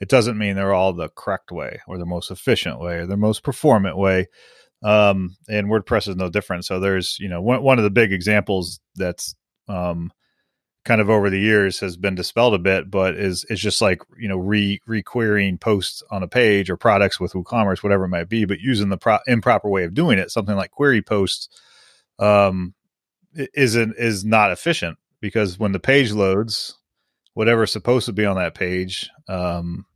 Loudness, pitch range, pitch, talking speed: -20 LUFS, 95-110 Hz, 100 Hz, 200 wpm